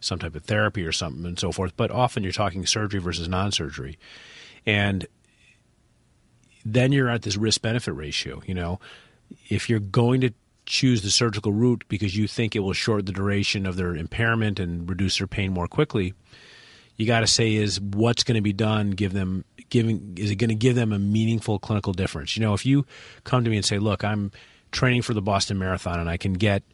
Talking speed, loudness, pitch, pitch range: 210 wpm, -24 LUFS, 105 Hz, 95-115 Hz